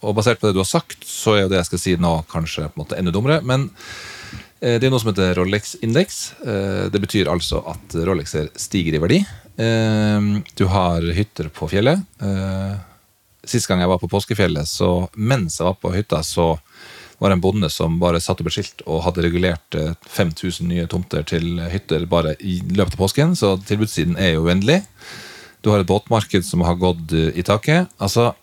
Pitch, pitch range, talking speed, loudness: 95 Hz, 85-105 Hz, 190 wpm, -19 LUFS